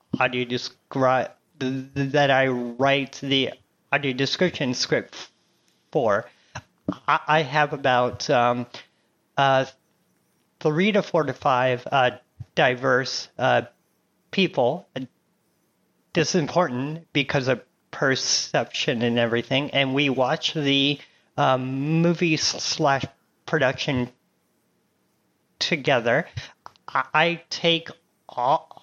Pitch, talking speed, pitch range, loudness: 140 Hz, 95 wpm, 130-155 Hz, -23 LUFS